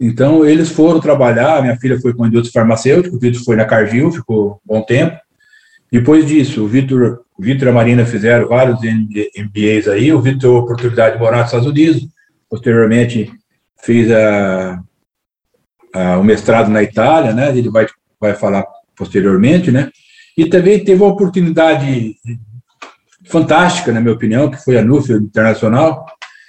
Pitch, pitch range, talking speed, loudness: 120 Hz, 110-155 Hz, 160 wpm, -12 LUFS